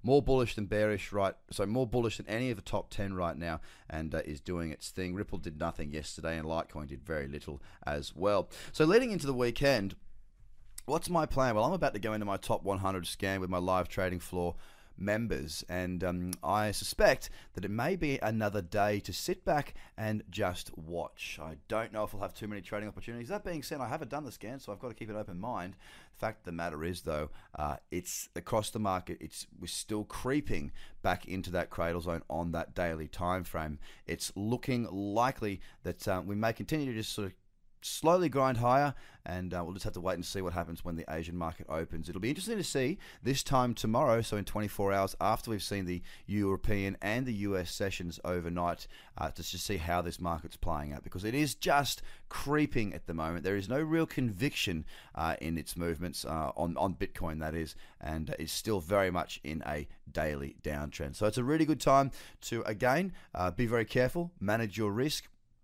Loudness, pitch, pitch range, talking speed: -34 LUFS, 95 Hz, 85-115 Hz, 215 wpm